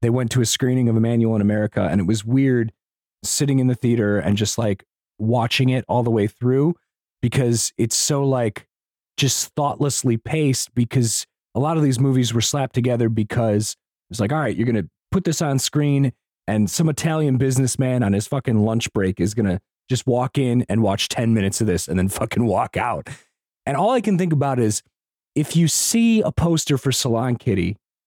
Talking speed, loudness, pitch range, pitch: 205 wpm, -20 LUFS, 110-135 Hz, 120 Hz